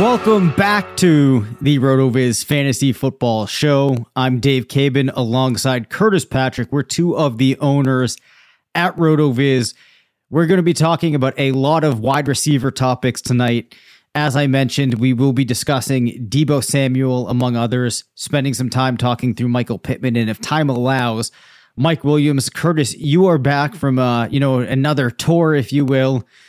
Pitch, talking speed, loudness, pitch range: 135 Hz, 160 wpm, -16 LUFS, 125-145 Hz